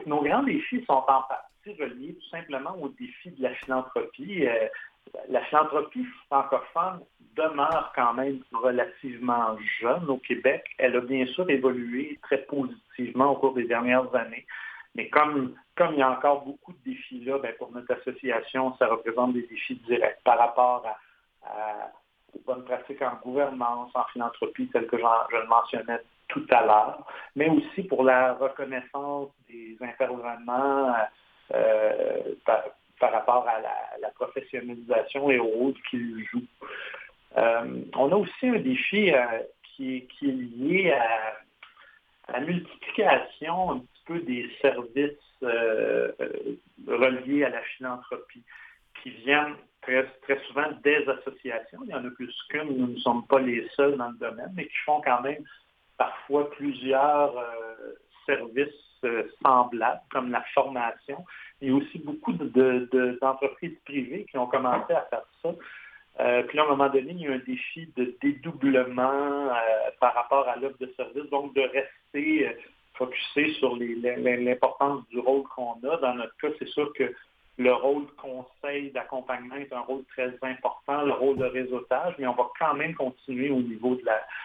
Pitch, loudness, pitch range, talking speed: 135 Hz, -27 LUFS, 125-145 Hz, 170 wpm